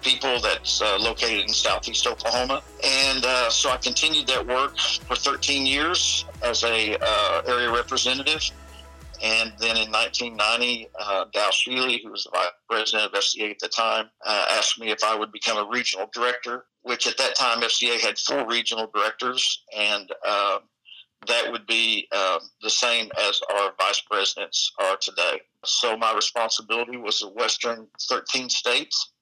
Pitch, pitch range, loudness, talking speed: 120 Hz, 110-125 Hz, -22 LUFS, 165 wpm